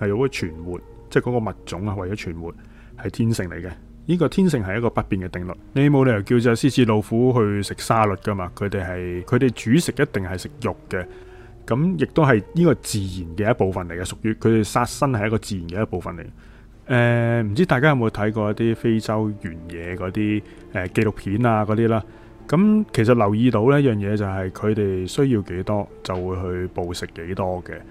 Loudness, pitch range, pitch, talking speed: -21 LUFS, 95-120 Hz, 110 Hz, 320 characters per minute